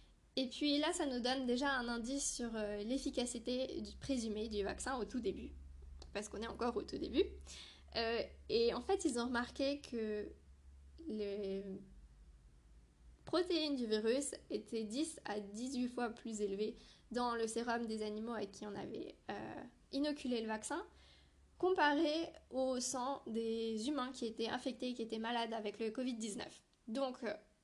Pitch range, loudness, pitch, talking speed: 210-270 Hz, -40 LUFS, 235 Hz, 155 wpm